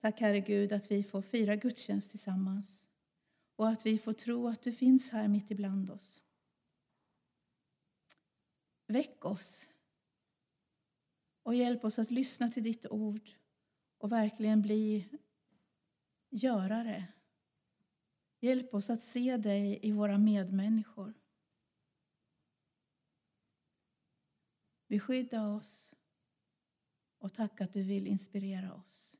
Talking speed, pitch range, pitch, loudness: 105 wpm, 200-235 Hz, 215 Hz, -34 LUFS